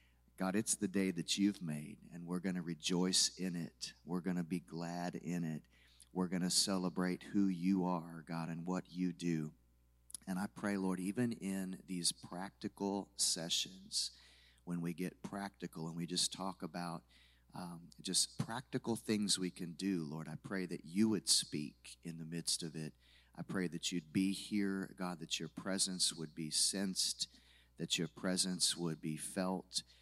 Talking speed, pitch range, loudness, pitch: 180 wpm, 80-95 Hz, -38 LUFS, 90 Hz